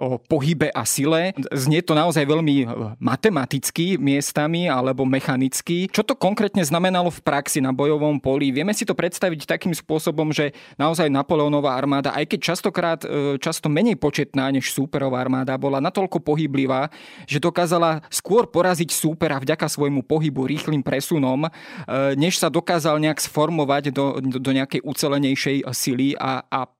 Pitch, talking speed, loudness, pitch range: 150 Hz, 150 wpm, -21 LUFS, 135-165 Hz